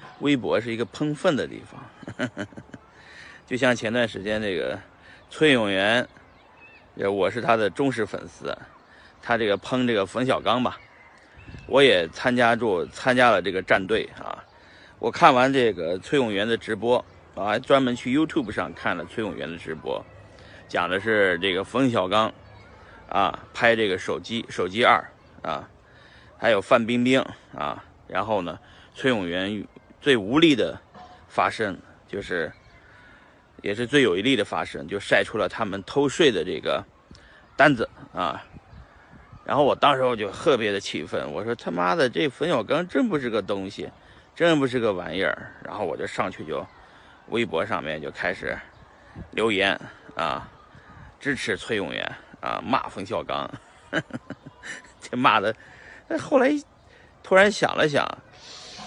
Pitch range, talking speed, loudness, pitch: 110-150 Hz, 220 characters per minute, -24 LUFS, 125 Hz